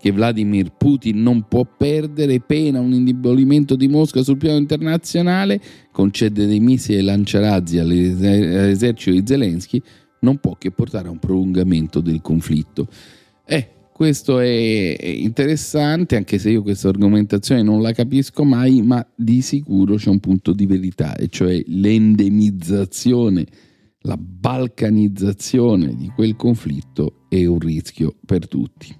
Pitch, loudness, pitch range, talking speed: 110 Hz, -17 LUFS, 100-130 Hz, 130 wpm